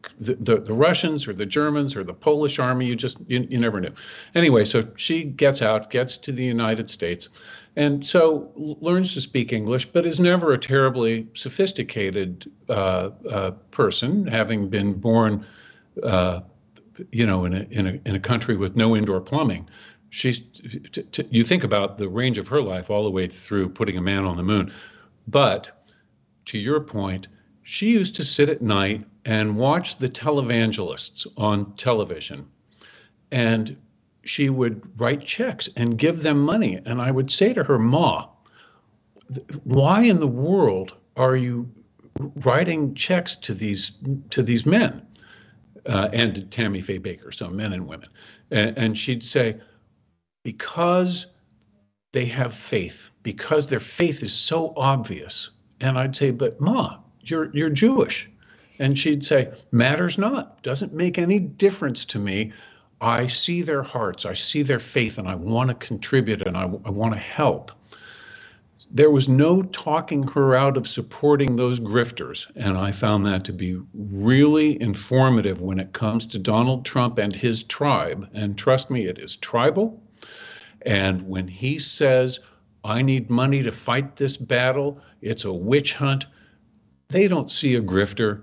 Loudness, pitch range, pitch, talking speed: -22 LUFS, 105-145 Hz, 125 Hz, 165 wpm